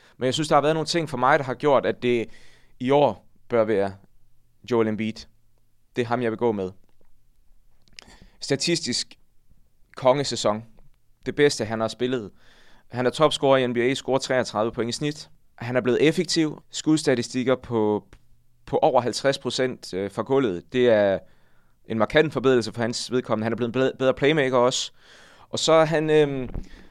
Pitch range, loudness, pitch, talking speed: 110-135 Hz, -23 LUFS, 125 Hz, 170 wpm